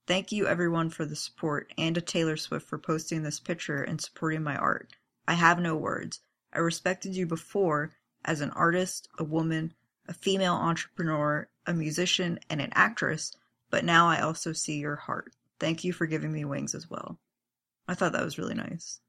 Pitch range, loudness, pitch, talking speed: 155-175 Hz, -29 LUFS, 165 Hz, 190 wpm